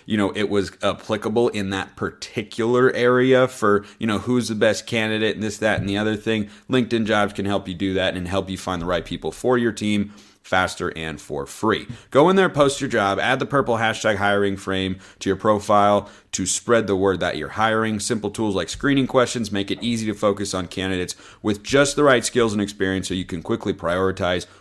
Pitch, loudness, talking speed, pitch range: 105 Hz, -21 LUFS, 220 wpm, 95-115 Hz